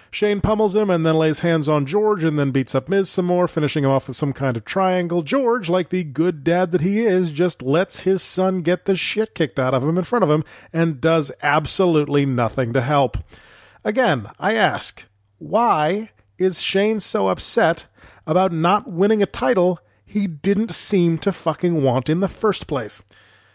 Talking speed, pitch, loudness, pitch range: 195 wpm, 170 Hz, -20 LUFS, 145-190 Hz